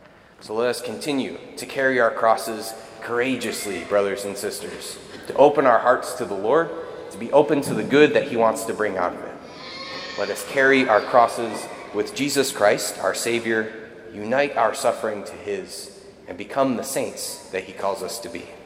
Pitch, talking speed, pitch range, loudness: 120 Hz, 185 wpm, 110-145 Hz, -22 LUFS